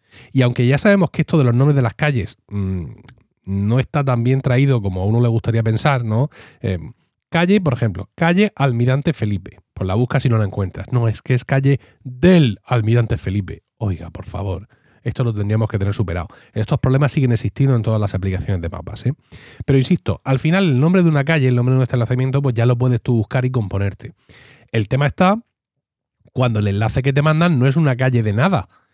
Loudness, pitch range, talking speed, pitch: -18 LUFS, 110-140 Hz, 220 wpm, 125 Hz